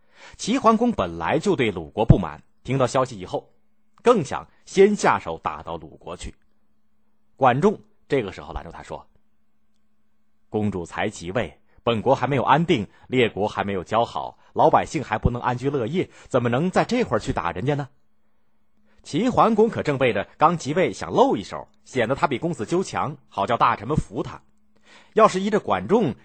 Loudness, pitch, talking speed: -22 LUFS, 130 Hz, 260 characters per minute